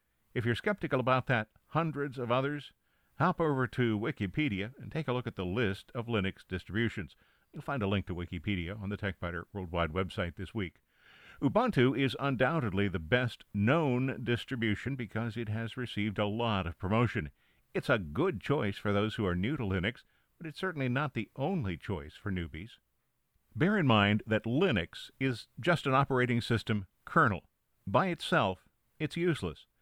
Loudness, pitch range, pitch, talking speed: -32 LUFS, 100-130 Hz, 115 Hz, 170 wpm